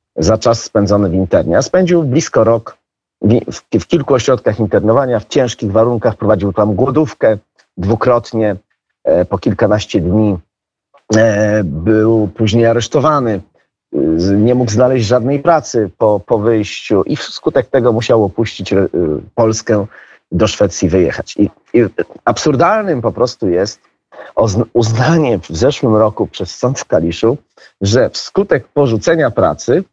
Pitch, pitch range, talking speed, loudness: 110 Hz, 105-120 Hz, 135 wpm, -13 LUFS